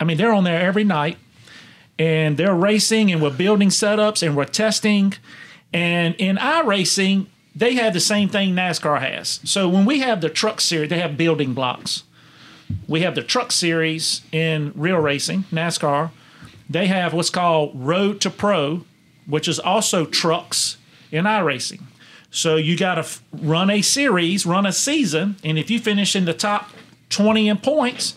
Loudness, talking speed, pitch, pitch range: -19 LUFS, 170 wpm, 175 Hz, 160-205 Hz